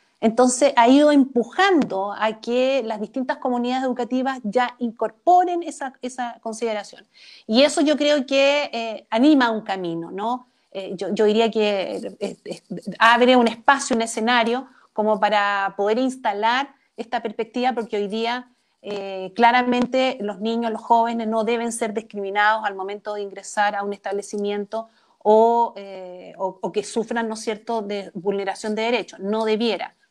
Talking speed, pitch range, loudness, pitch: 155 wpm, 205-250 Hz, -21 LUFS, 230 Hz